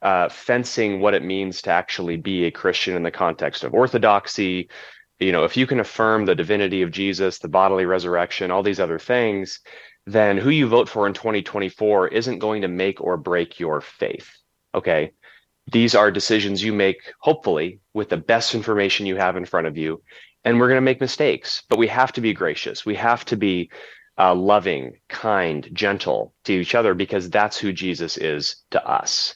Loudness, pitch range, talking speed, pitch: -21 LUFS, 95-115 Hz, 190 wpm, 100 Hz